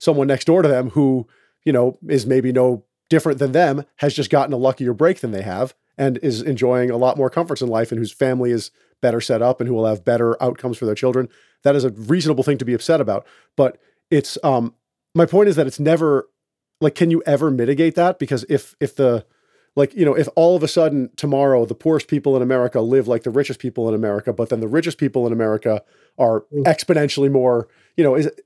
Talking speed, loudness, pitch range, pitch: 230 wpm, -18 LUFS, 125-150 Hz, 135 Hz